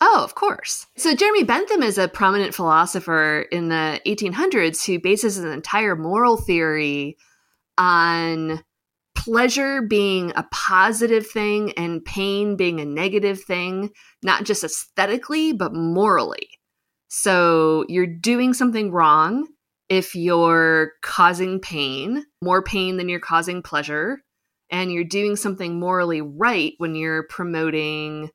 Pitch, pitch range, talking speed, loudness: 185 Hz, 165-215 Hz, 125 wpm, -20 LUFS